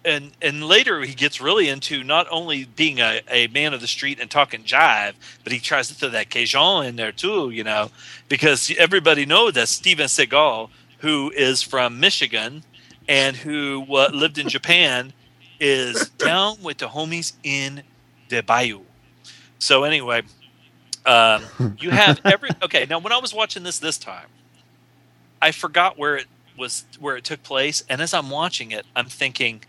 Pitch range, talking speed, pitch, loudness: 120-155 Hz, 175 wpm, 140 Hz, -18 LUFS